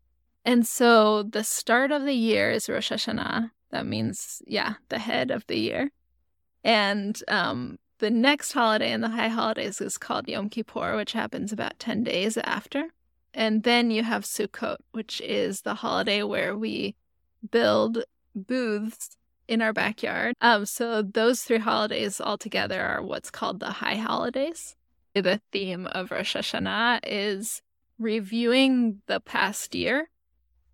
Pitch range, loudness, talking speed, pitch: 210-240 Hz, -26 LUFS, 150 wpm, 225 Hz